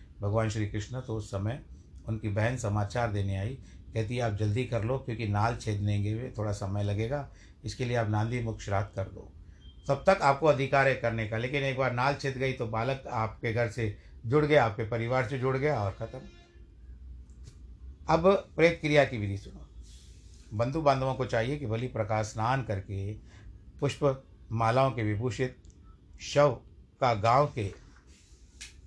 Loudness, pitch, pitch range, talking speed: -30 LUFS, 110 Hz, 100-130 Hz, 170 wpm